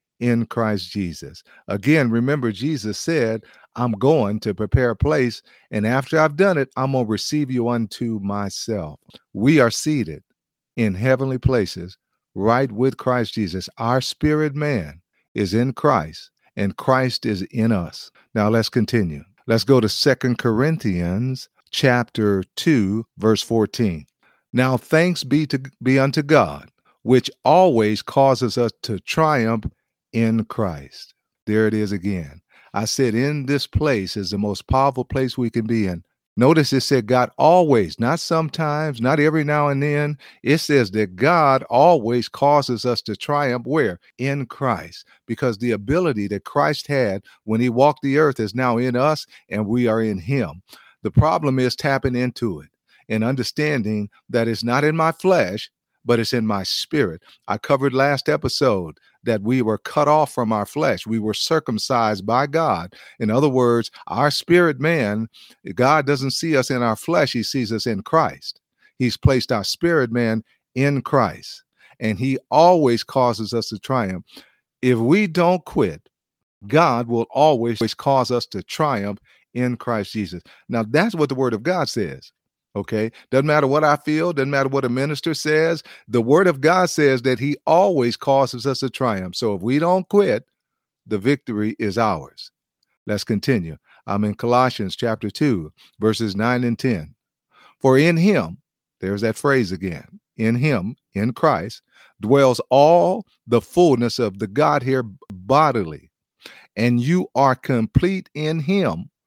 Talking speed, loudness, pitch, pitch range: 160 wpm, -20 LUFS, 125 Hz, 110-145 Hz